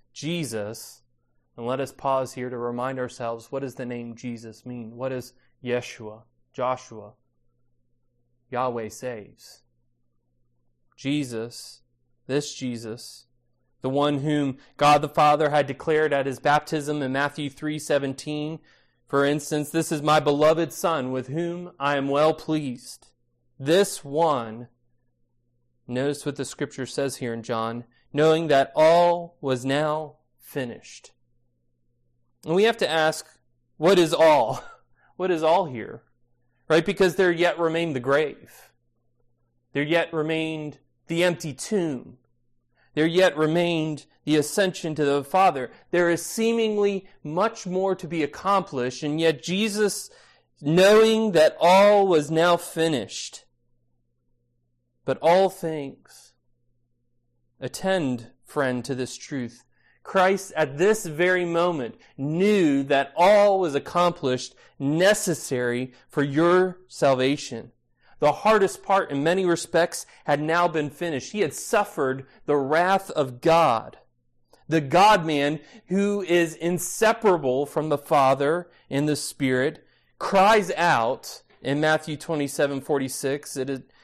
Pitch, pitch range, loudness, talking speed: 145 Hz, 120-165 Hz, -23 LUFS, 125 wpm